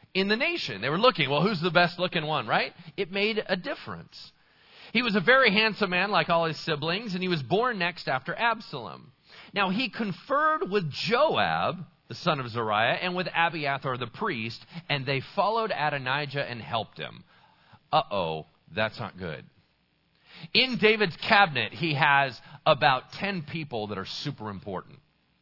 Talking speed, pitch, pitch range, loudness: 170 wpm, 165 Hz, 135-200 Hz, -26 LUFS